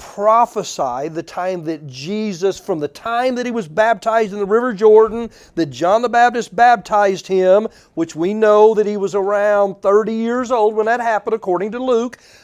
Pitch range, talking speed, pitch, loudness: 190-230 Hz, 185 wpm, 215 Hz, -16 LUFS